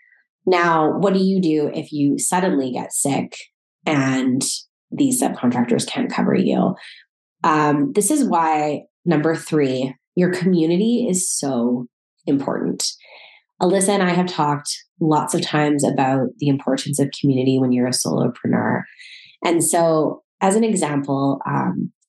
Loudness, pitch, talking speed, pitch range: -19 LUFS, 155 Hz, 135 wpm, 140-180 Hz